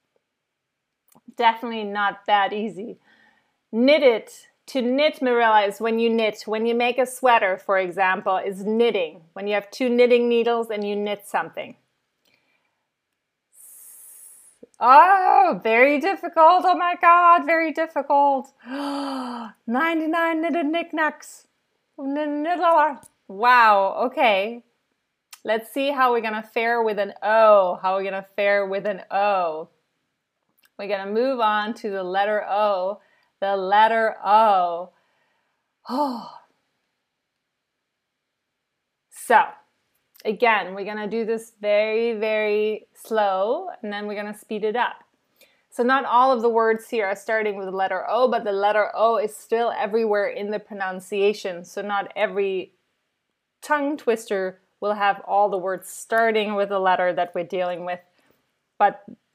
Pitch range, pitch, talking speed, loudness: 200-260 Hz, 220 Hz, 135 wpm, -21 LUFS